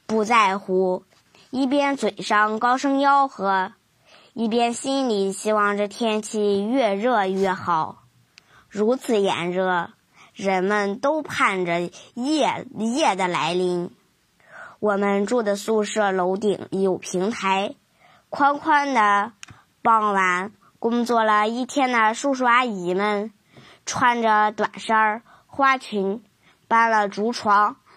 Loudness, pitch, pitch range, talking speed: -21 LUFS, 210 Hz, 195-240 Hz, 160 characters per minute